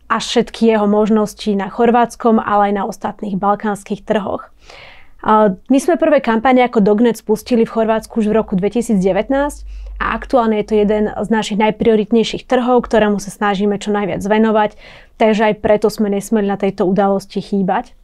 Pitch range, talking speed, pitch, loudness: 205-225 Hz, 165 wpm, 215 Hz, -15 LUFS